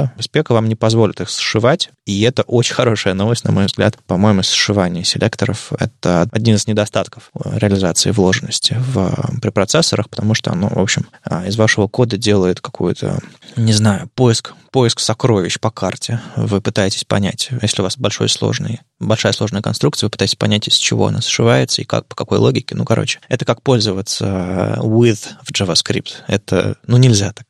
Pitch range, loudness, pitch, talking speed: 100-120 Hz, -15 LUFS, 110 Hz, 170 wpm